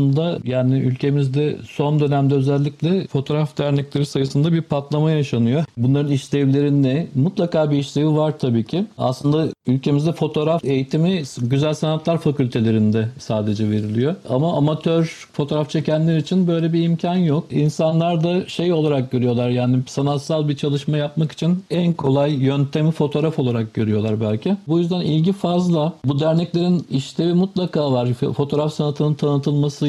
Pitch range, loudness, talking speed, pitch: 135-160 Hz, -19 LUFS, 140 wpm, 150 Hz